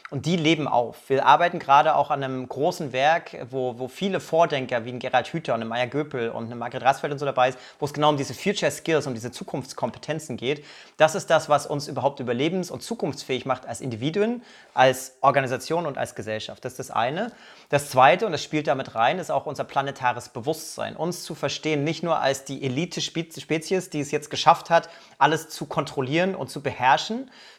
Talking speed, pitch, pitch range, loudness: 205 wpm, 145 Hz, 130-160 Hz, -24 LUFS